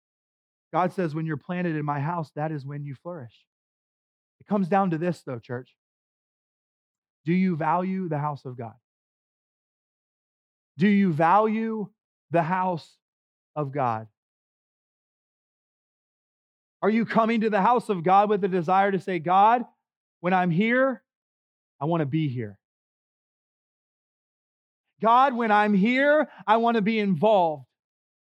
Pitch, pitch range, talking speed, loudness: 180 Hz, 150-210 Hz, 140 wpm, -24 LUFS